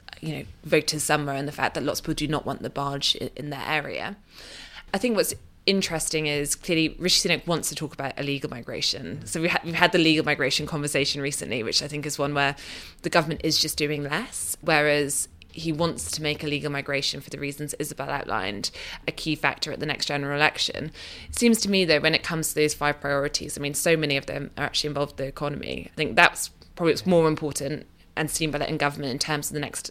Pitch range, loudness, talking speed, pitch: 140-160 Hz, -25 LUFS, 235 wpm, 150 Hz